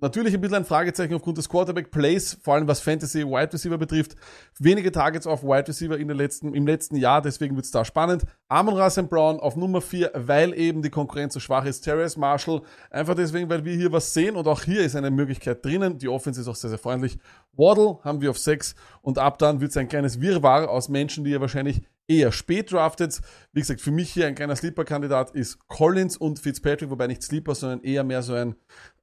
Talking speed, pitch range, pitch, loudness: 215 wpm, 140-165 Hz, 150 Hz, -24 LUFS